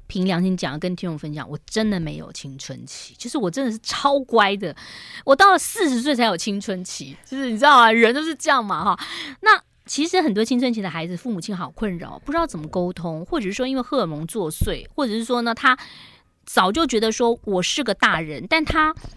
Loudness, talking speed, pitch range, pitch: -20 LUFS, 330 characters per minute, 180-280 Hz, 225 Hz